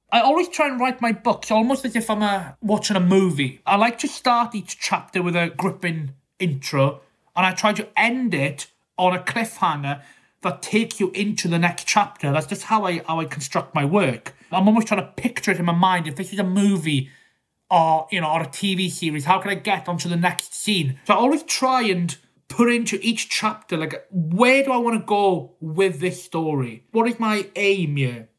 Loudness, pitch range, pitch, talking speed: -21 LUFS, 160-215 Hz, 190 Hz, 220 wpm